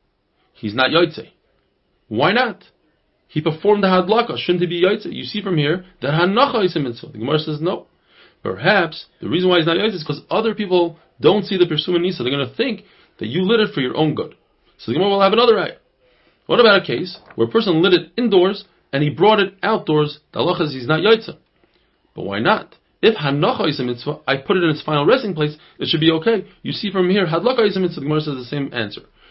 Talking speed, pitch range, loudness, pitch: 235 wpm, 150-200 Hz, -18 LUFS, 175 Hz